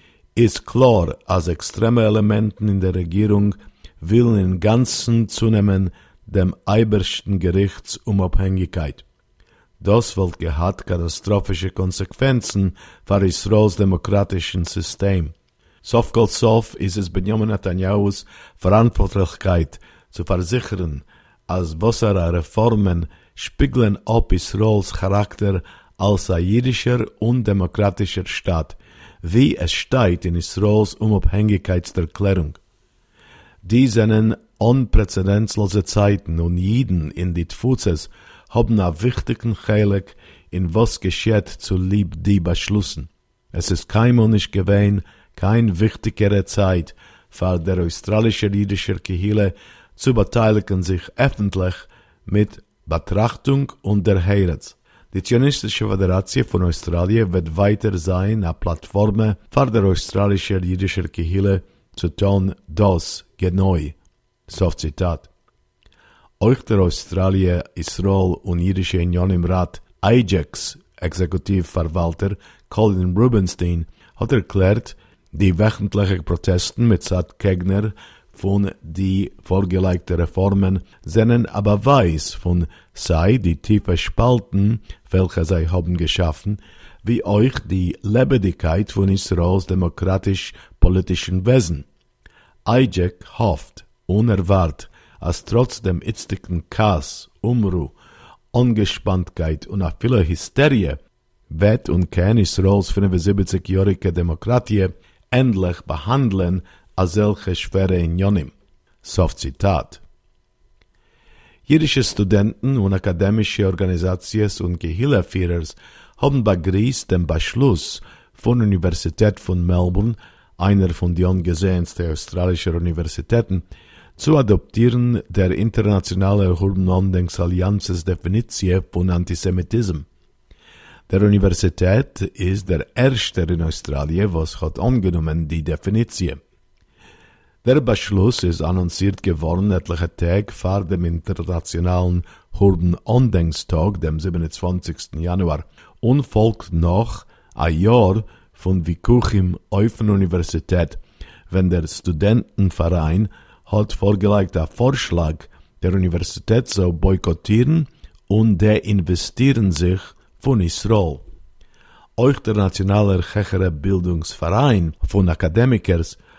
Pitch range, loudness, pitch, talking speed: 90-105 Hz, -19 LUFS, 95 Hz, 95 wpm